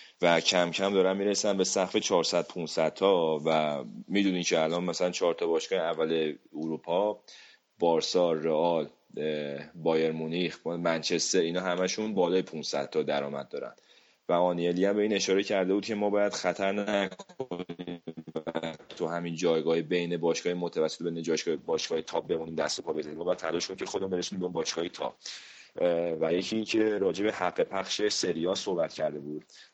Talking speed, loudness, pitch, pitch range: 160 wpm, -29 LUFS, 90 Hz, 80-100 Hz